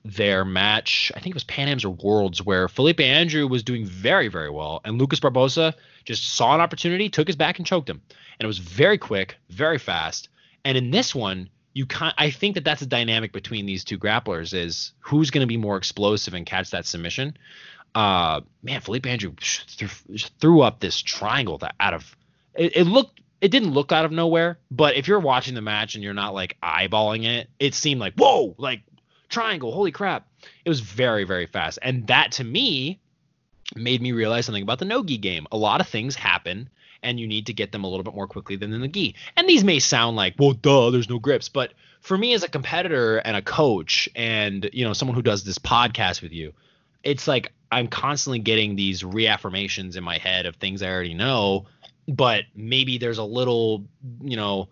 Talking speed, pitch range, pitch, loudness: 210 wpm, 100-145 Hz, 120 Hz, -22 LUFS